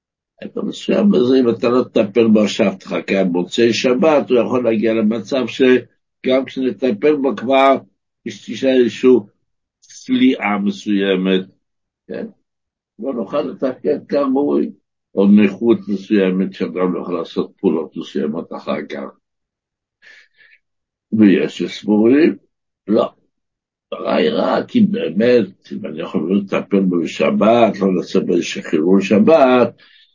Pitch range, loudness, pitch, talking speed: 100-130 Hz, -16 LUFS, 115 Hz, 115 wpm